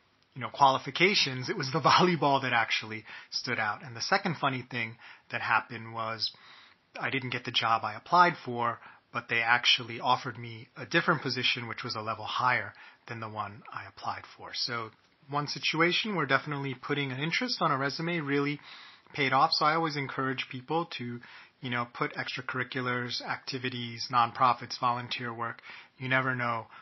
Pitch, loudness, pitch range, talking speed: 130 Hz, -29 LUFS, 120-145 Hz, 170 wpm